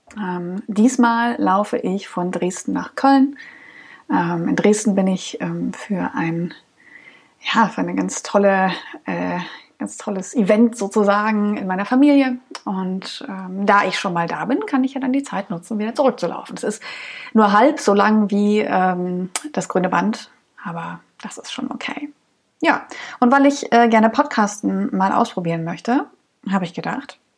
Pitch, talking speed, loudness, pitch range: 210 Hz, 165 wpm, -19 LUFS, 185-250 Hz